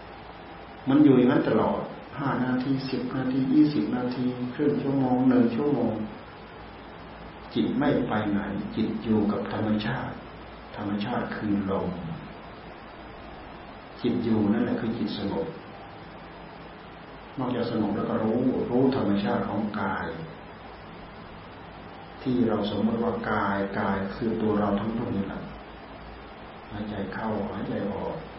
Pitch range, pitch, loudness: 100-125 Hz, 110 Hz, -27 LUFS